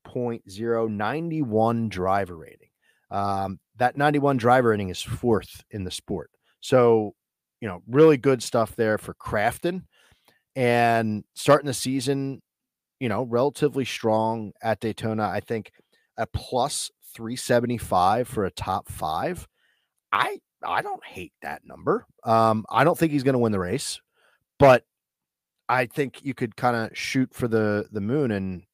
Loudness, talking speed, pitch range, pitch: -24 LUFS, 150 wpm, 110-135 Hz, 115 Hz